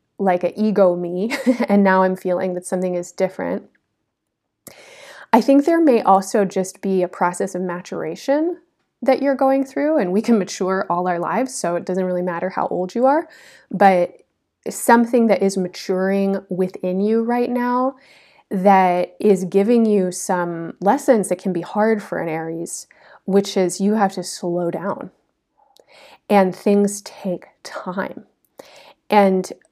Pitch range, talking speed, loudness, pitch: 185-245 Hz, 155 wpm, -19 LUFS, 195 Hz